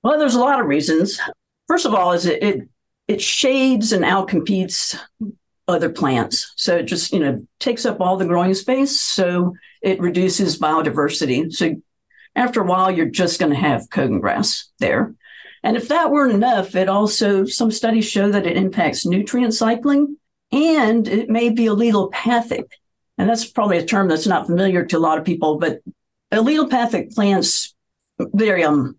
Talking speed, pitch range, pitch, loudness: 170 wpm, 180-240 Hz, 205 Hz, -18 LUFS